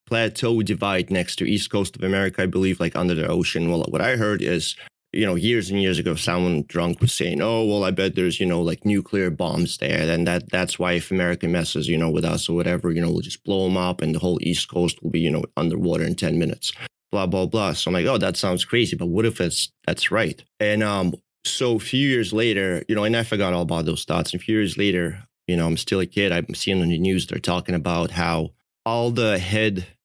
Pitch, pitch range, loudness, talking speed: 90 Hz, 85-105 Hz, -22 LUFS, 255 wpm